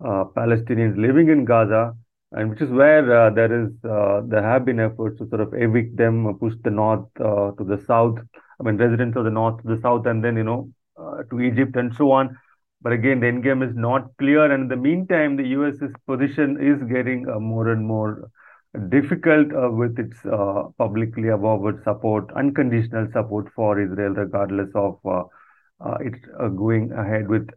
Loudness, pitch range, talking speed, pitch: -20 LUFS, 110-130 Hz, 200 wpm, 115 Hz